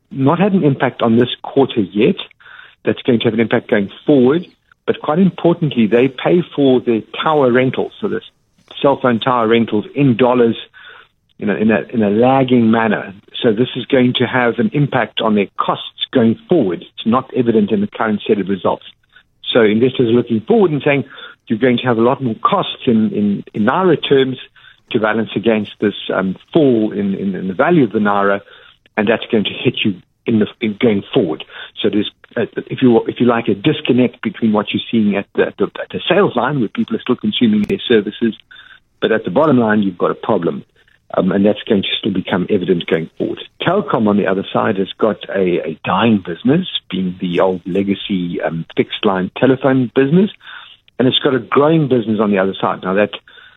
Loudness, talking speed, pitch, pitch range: -15 LUFS, 210 wpm, 120 Hz, 105-135 Hz